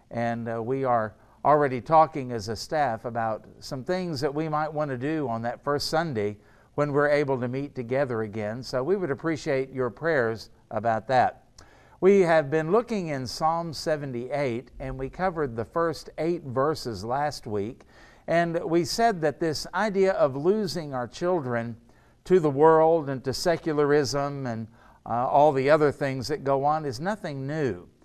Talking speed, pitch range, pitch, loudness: 175 wpm, 120-160 Hz, 140 Hz, -26 LUFS